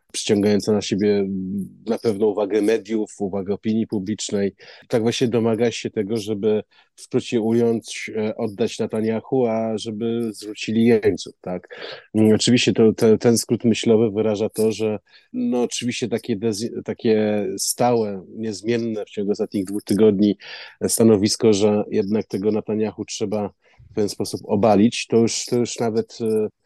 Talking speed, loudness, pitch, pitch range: 135 wpm, -21 LUFS, 110 Hz, 105-115 Hz